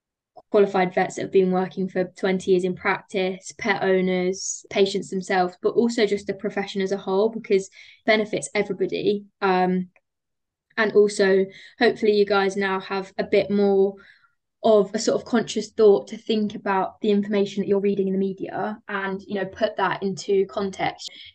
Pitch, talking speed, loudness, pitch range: 200 Hz, 175 wpm, -23 LUFS, 190-210 Hz